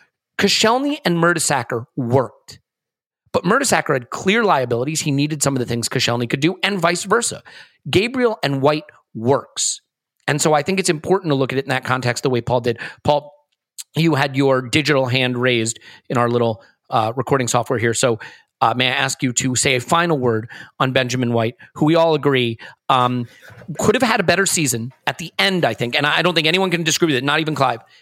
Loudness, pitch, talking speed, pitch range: -18 LUFS, 140 Hz, 210 wpm, 125-165 Hz